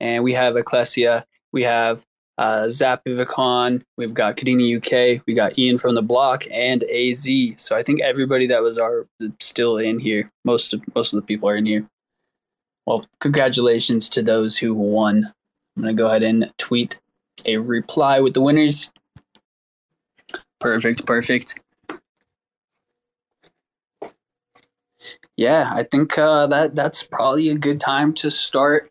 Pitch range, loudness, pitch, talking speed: 115-135 Hz, -19 LUFS, 120 Hz, 145 wpm